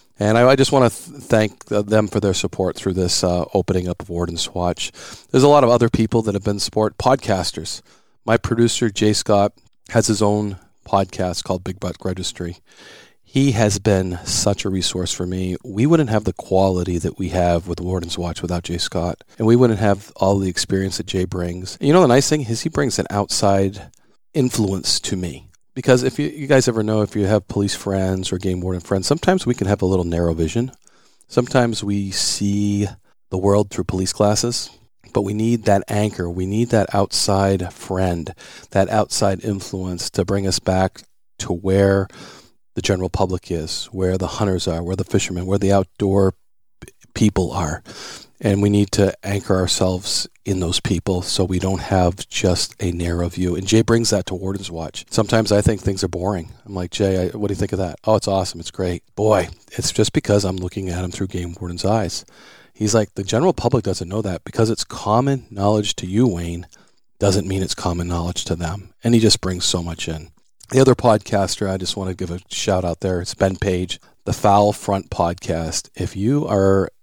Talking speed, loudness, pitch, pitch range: 205 wpm, -19 LUFS, 100 Hz, 90-110 Hz